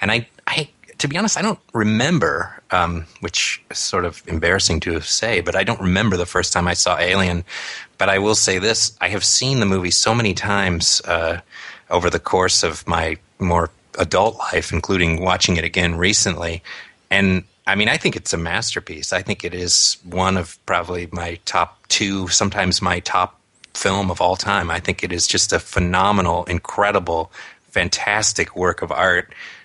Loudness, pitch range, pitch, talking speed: -18 LUFS, 90-105 Hz, 95 Hz, 185 wpm